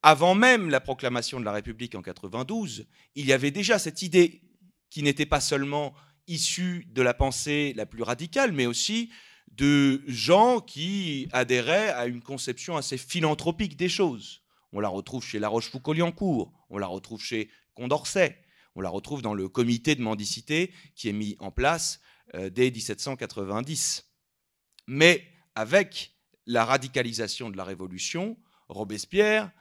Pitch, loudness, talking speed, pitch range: 135 Hz, -26 LUFS, 150 wpm, 115-170 Hz